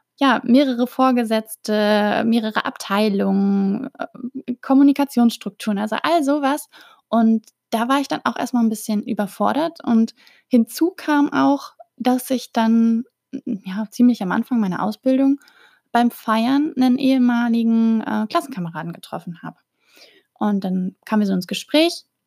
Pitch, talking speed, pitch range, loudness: 235 Hz, 125 wpm, 220-275 Hz, -19 LUFS